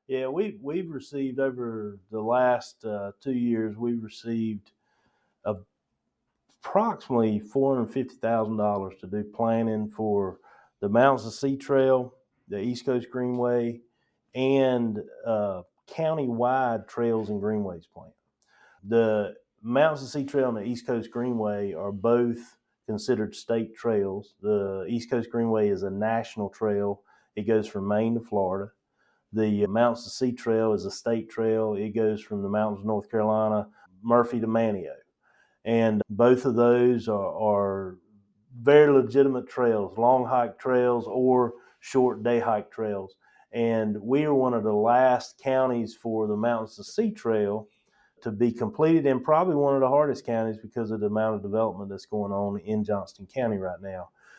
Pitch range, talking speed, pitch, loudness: 105-125 Hz, 155 wpm, 115 Hz, -26 LUFS